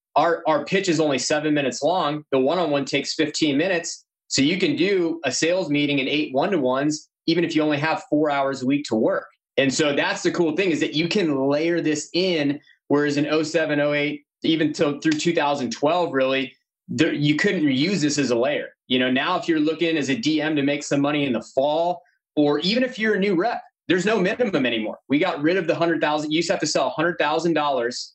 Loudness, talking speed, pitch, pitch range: -22 LUFS, 230 wpm, 155 Hz, 145-170 Hz